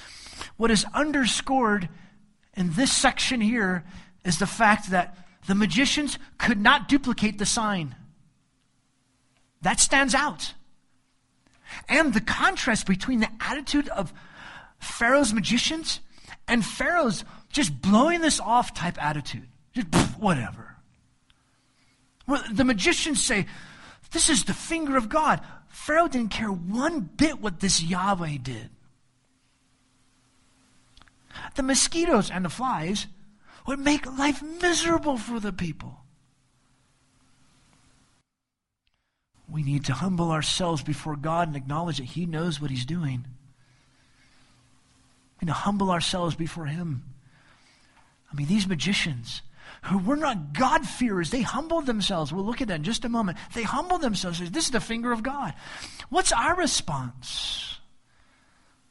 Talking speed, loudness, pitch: 130 wpm, -25 LUFS, 195 Hz